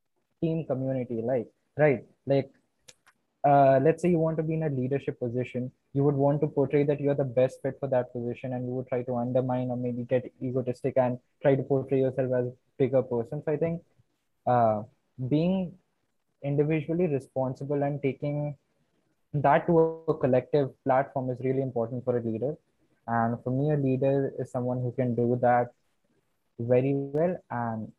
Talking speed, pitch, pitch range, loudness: 175 wpm, 135 Hz, 125-145 Hz, -28 LUFS